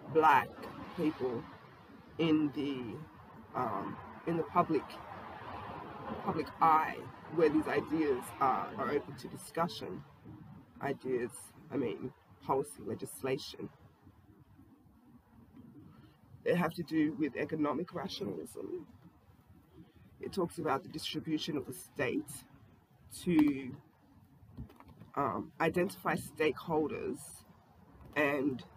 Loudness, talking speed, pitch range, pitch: -35 LUFS, 90 wpm, 140-175 Hz, 155 Hz